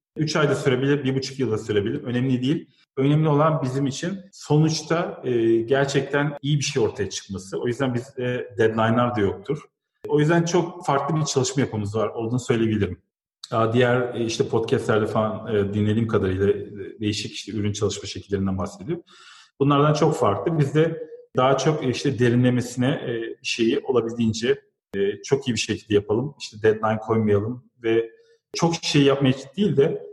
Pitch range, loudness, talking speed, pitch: 110-150 Hz, -23 LUFS, 160 wpm, 130 Hz